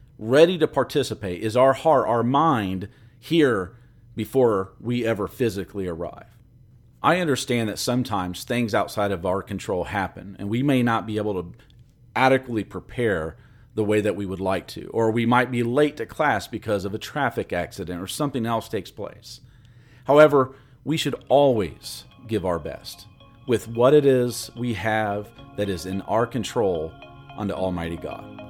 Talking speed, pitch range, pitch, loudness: 165 wpm, 100-125 Hz, 115 Hz, -23 LUFS